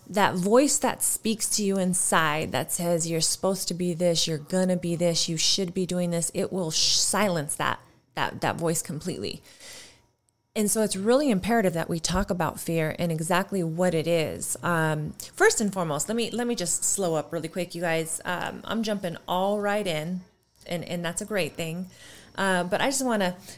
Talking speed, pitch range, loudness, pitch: 200 wpm, 165-200 Hz, -26 LUFS, 180 Hz